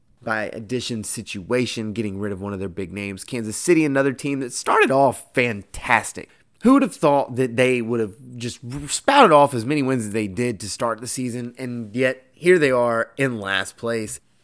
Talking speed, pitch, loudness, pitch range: 200 wpm, 120 Hz, -21 LUFS, 110-130 Hz